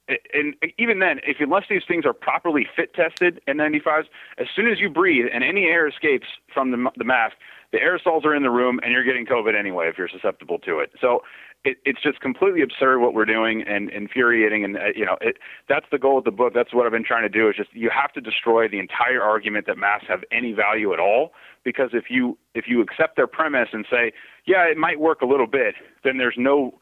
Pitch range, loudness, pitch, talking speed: 115-180 Hz, -21 LUFS, 135 Hz, 235 wpm